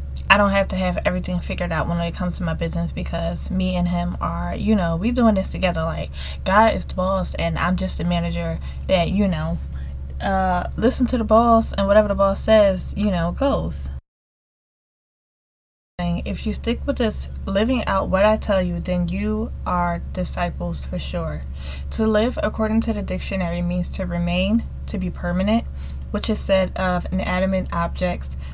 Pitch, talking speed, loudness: 175 Hz, 180 wpm, -21 LUFS